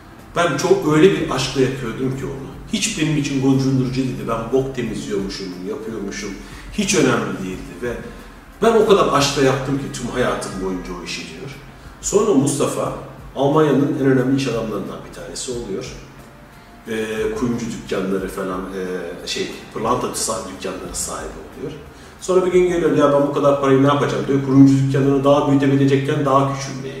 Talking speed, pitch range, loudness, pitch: 155 wpm, 110-140 Hz, -19 LUFS, 135 Hz